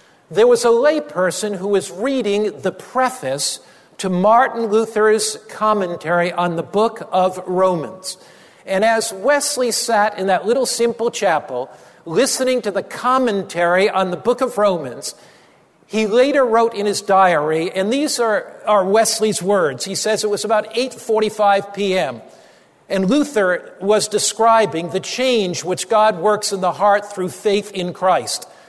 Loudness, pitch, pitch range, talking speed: -17 LUFS, 205 Hz, 185-230 Hz, 150 wpm